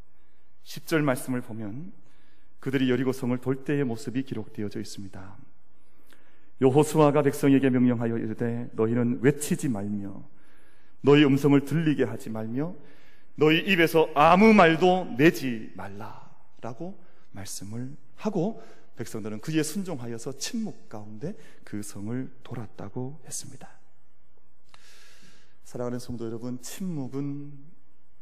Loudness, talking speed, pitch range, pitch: -25 LUFS, 265 characters per minute, 110-150 Hz, 130 Hz